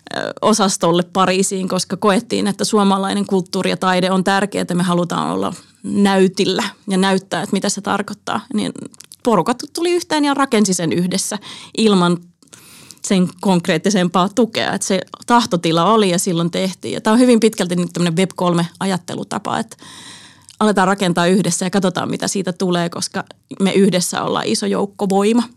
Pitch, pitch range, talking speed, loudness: 195 Hz, 185-210 Hz, 150 wpm, -17 LUFS